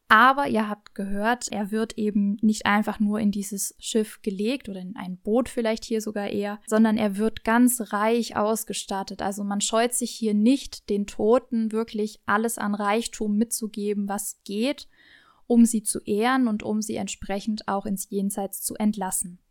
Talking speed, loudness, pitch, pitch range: 170 wpm, -25 LUFS, 215 Hz, 205-225 Hz